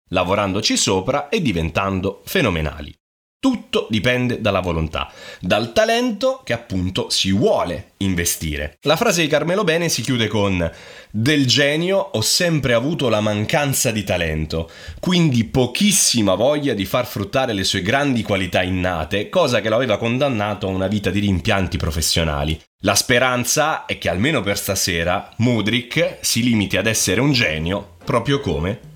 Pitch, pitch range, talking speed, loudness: 105 Hz, 95-135 Hz, 145 wpm, -18 LUFS